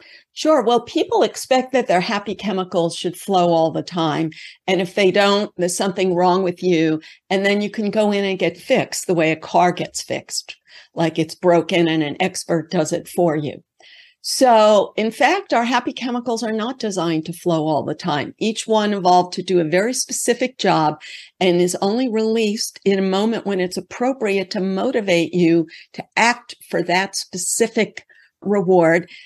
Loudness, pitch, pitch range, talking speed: -19 LUFS, 190 Hz, 175-220 Hz, 185 wpm